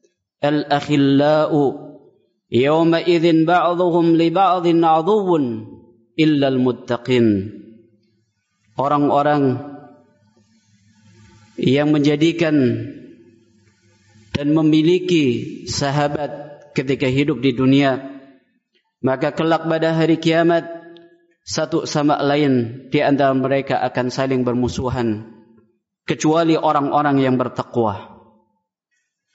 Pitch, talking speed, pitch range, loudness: 145 Hz, 70 wpm, 120-160 Hz, -18 LUFS